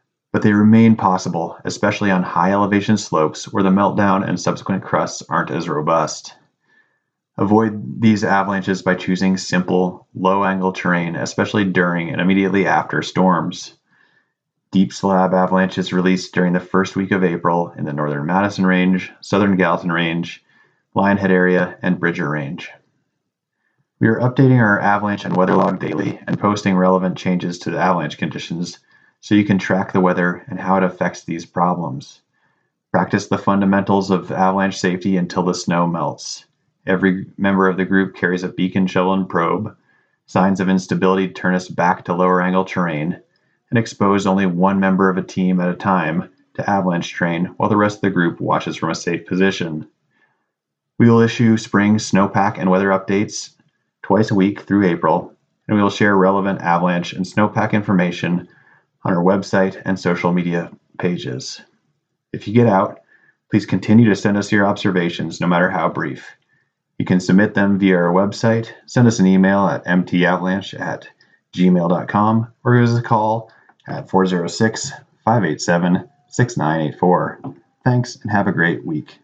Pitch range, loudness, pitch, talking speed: 90-100 Hz, -17 LUFS, 95 Hz, 160 wpm